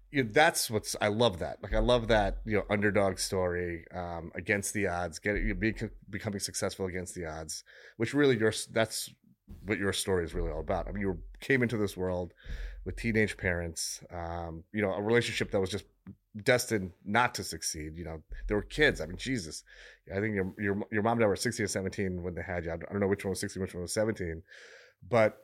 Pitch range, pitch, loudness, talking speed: 90-110 Hz, 100 Hz, -31 LUFS, 230 wpm